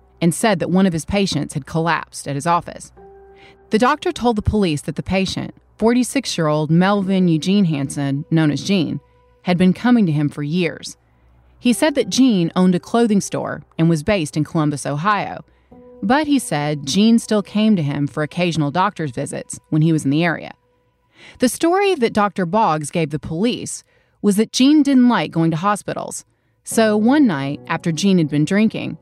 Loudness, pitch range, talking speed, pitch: -18 LUFS, 155-220 Hz, 190 wpm, 180 Hz